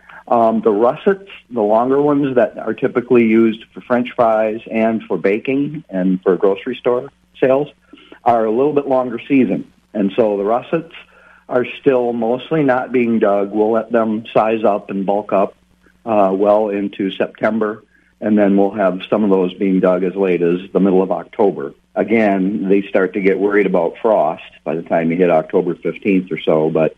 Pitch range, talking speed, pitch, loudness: 100-125 Hz, 185 wpm, 110 Hz, -16 LUFS